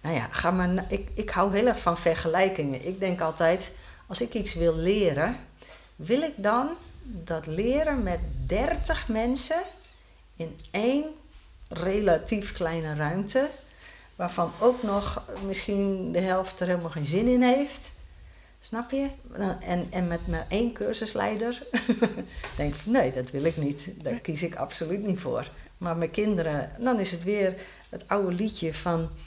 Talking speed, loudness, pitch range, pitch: 160 wpm, -28 LUFS, 170-235 Hz, 190 Hz